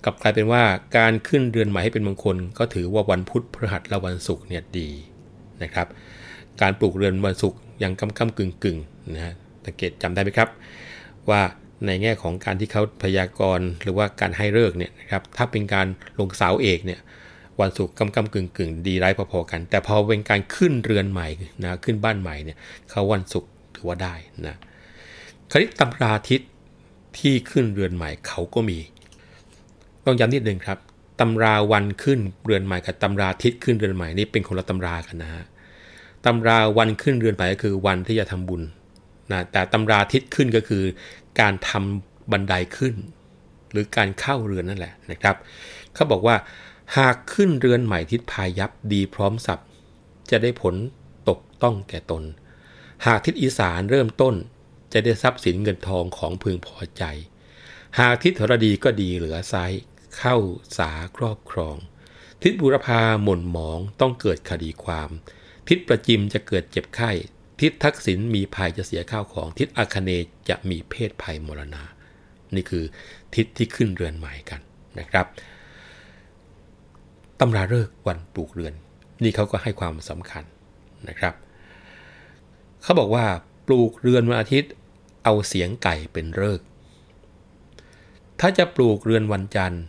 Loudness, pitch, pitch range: -22 LUFS, 95 Hz, 90-110 Hz